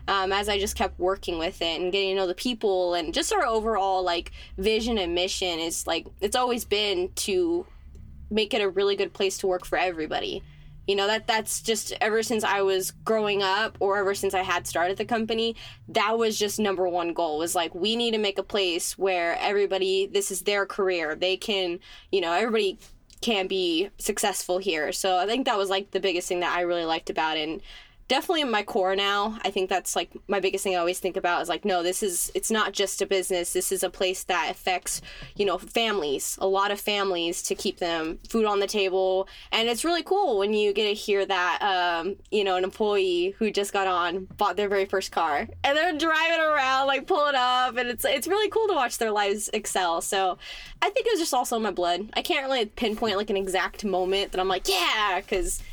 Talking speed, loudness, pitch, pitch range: 230 wpm, -25 LUFS, 195 Hz, 185-225 Hz